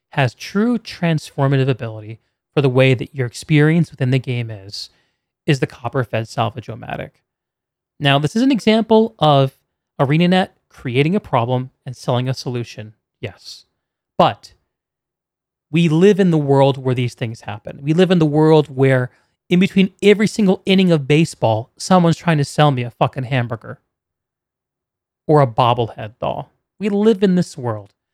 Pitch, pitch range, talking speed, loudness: 140 Hz, 125-170 Hz, 160 wpm, -17 LUFS